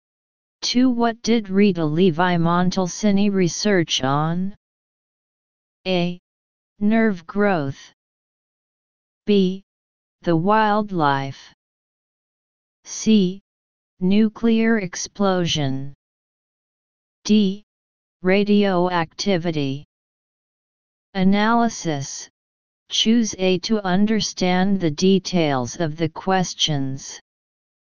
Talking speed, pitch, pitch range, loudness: 60 wpm, 185 Hz, 160-205 Hz, -20 LUFS